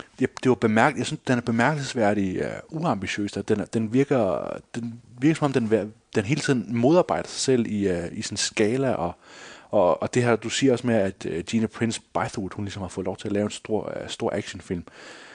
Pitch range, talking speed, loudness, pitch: 105-125 Hz, 220 wpm, -25 LUFS, 115 Hz